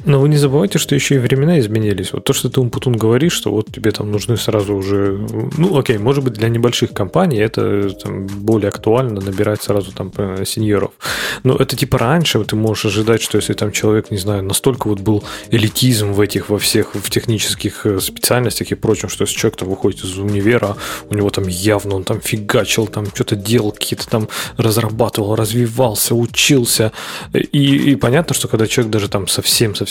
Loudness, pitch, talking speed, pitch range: -16 LUFS, 110 Hz, 185 wpm, 105-125 Hz